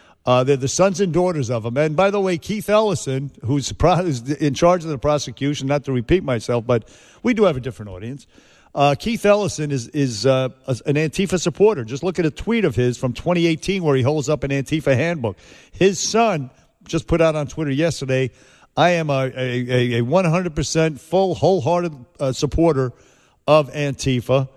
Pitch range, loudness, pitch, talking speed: 130-175 Hz, -19 LUFS, 150 Hz, 185 wpm